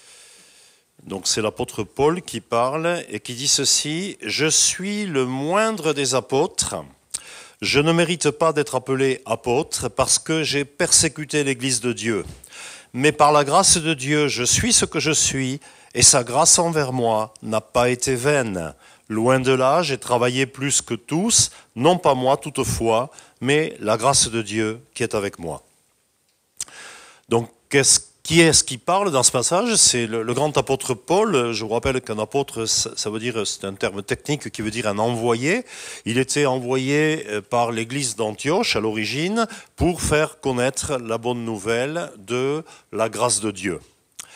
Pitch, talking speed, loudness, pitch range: 130 Hz, 165 wpm, -20 LUFS, 115-150 Hz